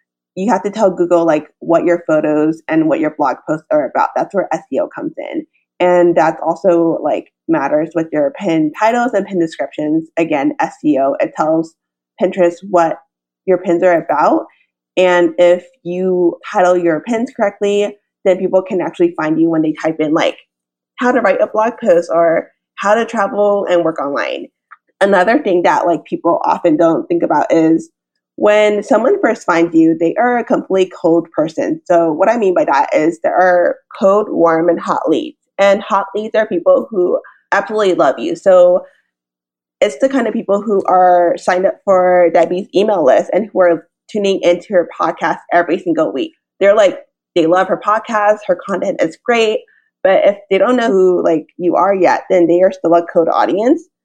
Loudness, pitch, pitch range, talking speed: -14 LUFS, 180 Hz, 170-220 Hz, 190 wpm